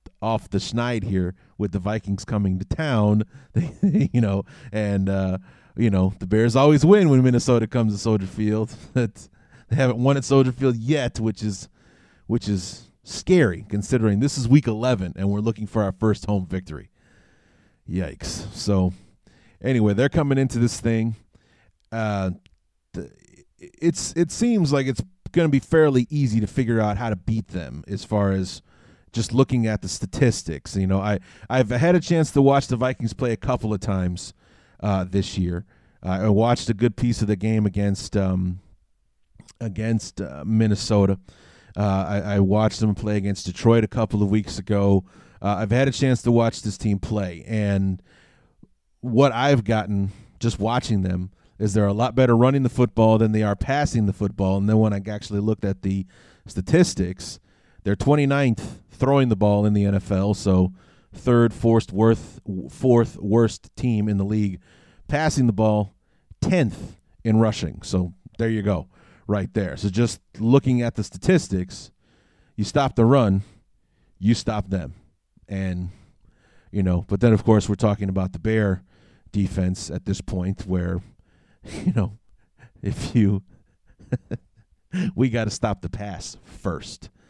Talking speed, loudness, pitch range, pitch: 165 wpm, -22 LUFS, 95-120 Hz, 105 Hz